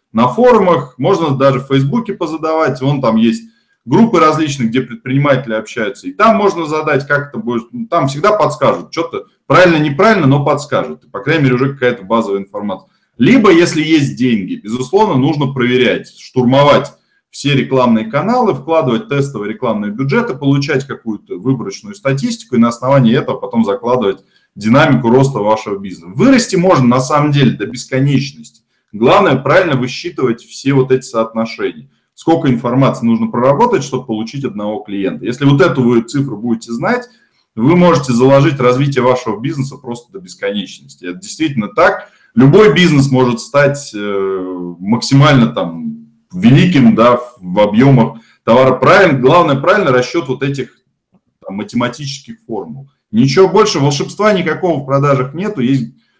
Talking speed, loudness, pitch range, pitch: 145 wpm, -12 LUFS, 120-160 Hz, 135 Hz